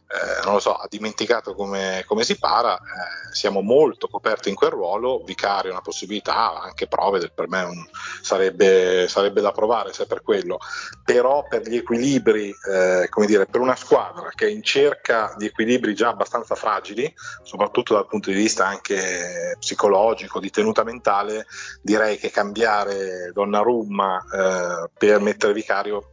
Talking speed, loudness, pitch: 170 wpm, -21 LUFS, 115 Hz